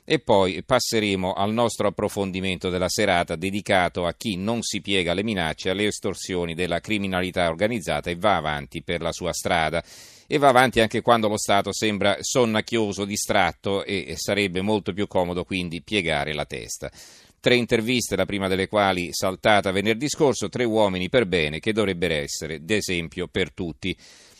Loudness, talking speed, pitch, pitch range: -23 LUFS, 160 wpm, 100 Hz, 90-105 Hz